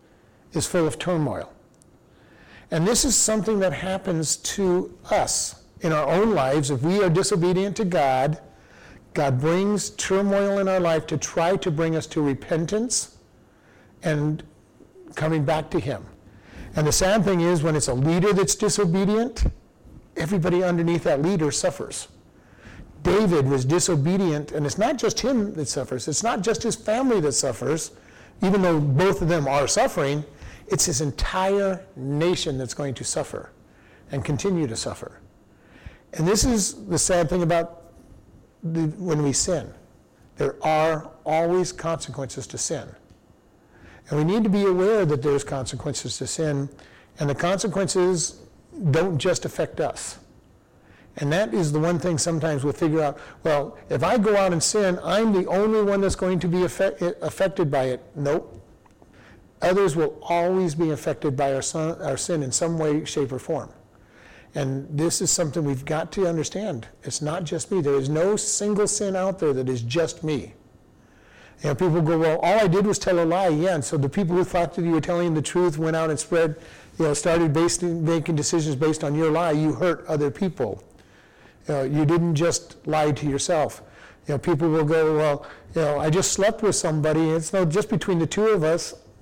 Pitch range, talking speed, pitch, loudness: 145-185 Hz, 180 wpm, 165 Hz, -23 LUFS